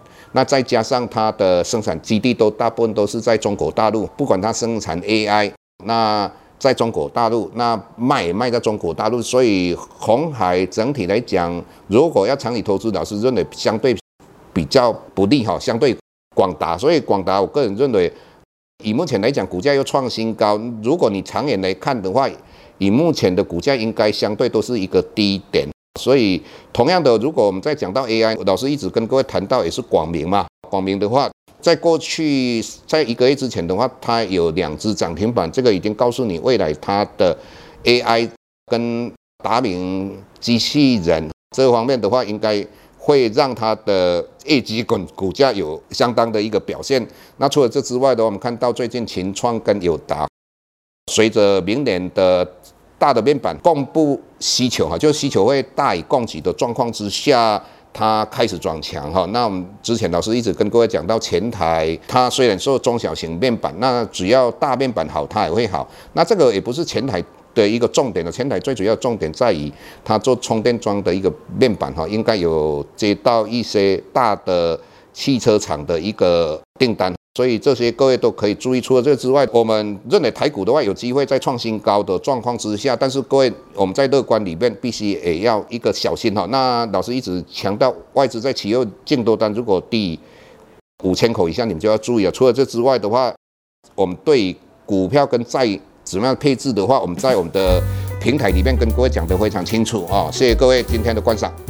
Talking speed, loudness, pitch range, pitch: 285 characters per minute, -18 LUFS, 100-125 Hz, 115 Hz